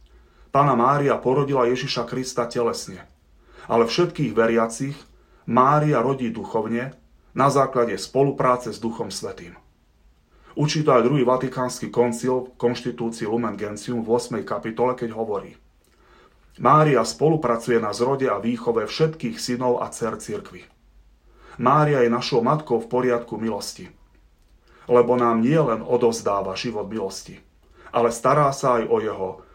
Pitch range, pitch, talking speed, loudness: 115-130 Hz, 120 Hz, 130 wpm, -22 LUFS